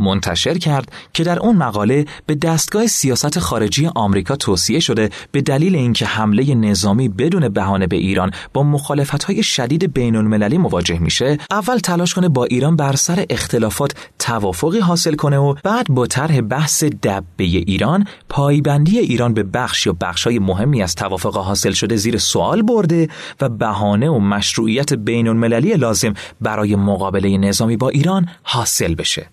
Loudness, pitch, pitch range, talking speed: -16 LUFS, 130 Hz, 105-155 Hz, 160 wpm